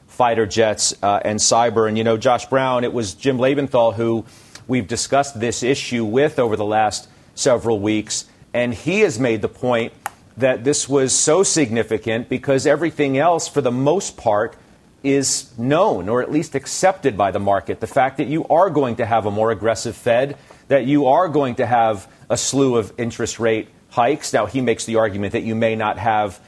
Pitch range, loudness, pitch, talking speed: 110-135 Hz, -19 LUFS, 120 Hz, 195 wpm